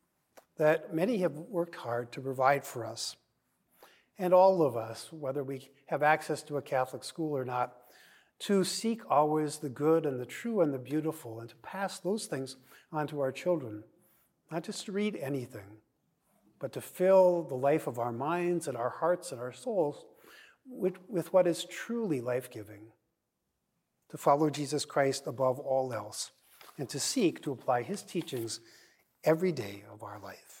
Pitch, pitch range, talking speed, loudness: 150 Hz, 125-175 Hz, 175 wpm, -32 LUFS